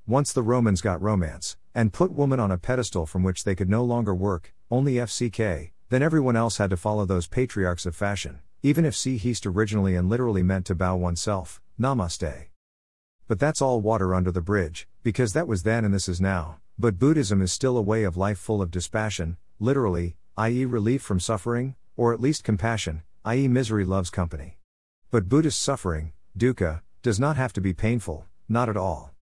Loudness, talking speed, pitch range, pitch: -25 LUFS, 190 wpm, 90-120 Hz, 105 Hz